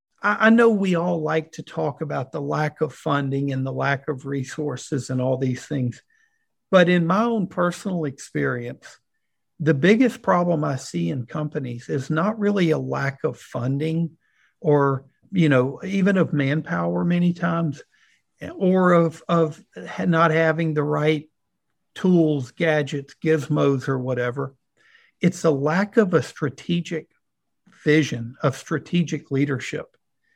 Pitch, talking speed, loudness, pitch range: 155 Hz, 140 wpm, -22 LUFS, 140-175 Hz